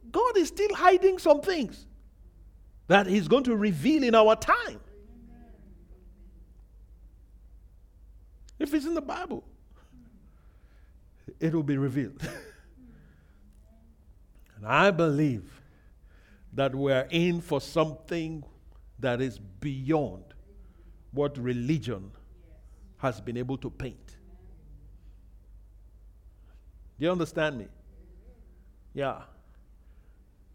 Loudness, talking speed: -27 LUFS, 90 wpm